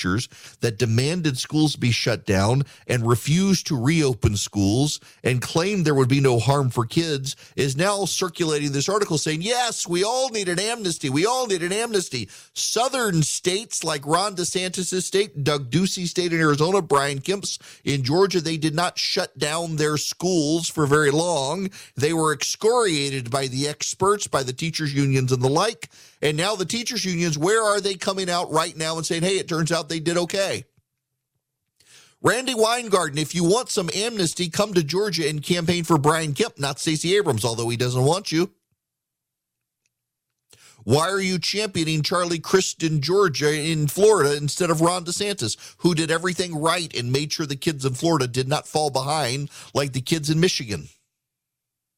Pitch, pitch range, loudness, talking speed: 160 Hz, 140-180 Hz, -22 LUFS, 175 wpm